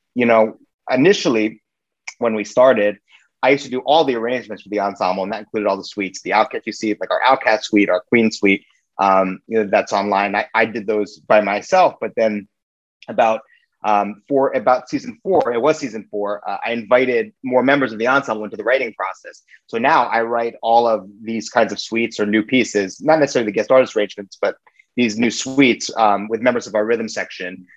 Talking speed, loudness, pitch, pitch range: 210 wpm, -18 LUFS, 110 Hz, 100-125 Hz